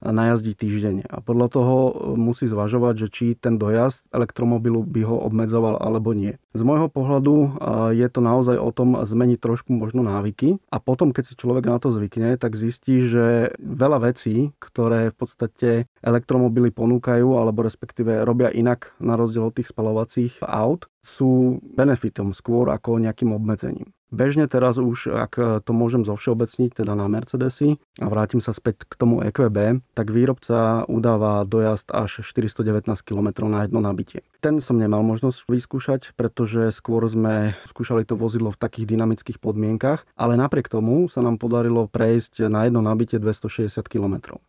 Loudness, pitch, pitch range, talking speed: -21 LUFS, 115 Hz, 110-125 Hz, 160 wpm